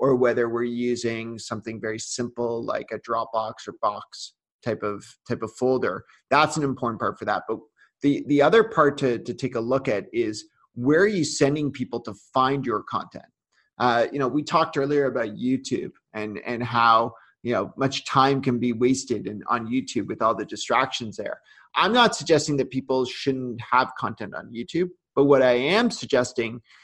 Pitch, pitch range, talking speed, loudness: 125 Hz, 115-145 Hz, 190 wpm, -24 LUFS